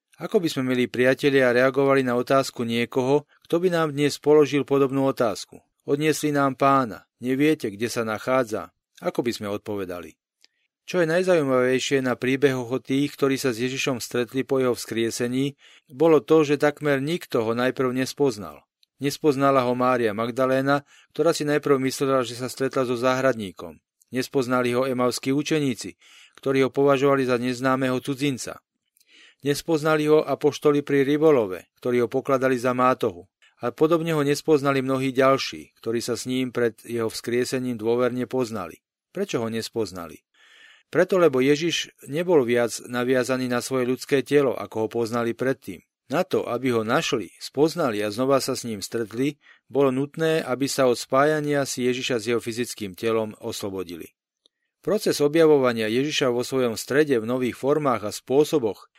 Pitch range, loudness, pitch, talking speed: 120-145 Hz, -23 LUFS, 130 Hz, 155 wpm